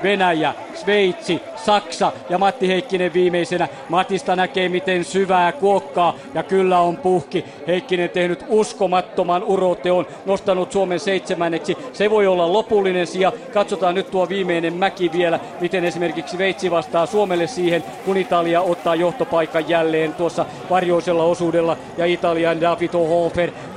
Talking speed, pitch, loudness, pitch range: 130 wpm, 180 Hz, -19 LUFS, 170-190 Hz